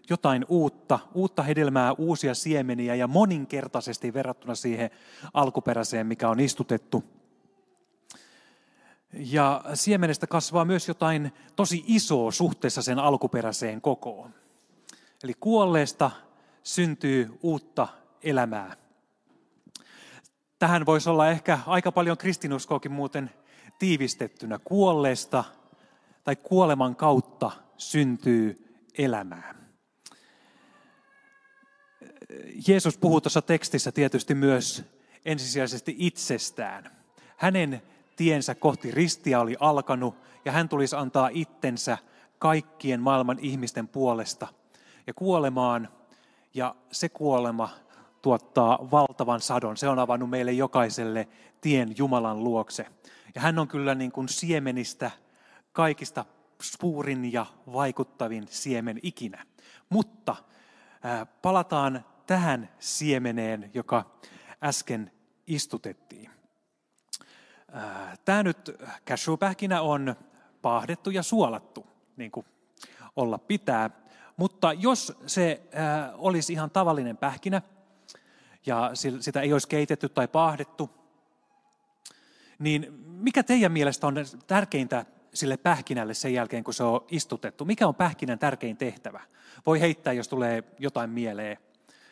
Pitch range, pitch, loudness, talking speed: 125-170 Hz, 145 Hz, -27 LUFS, 100 wpm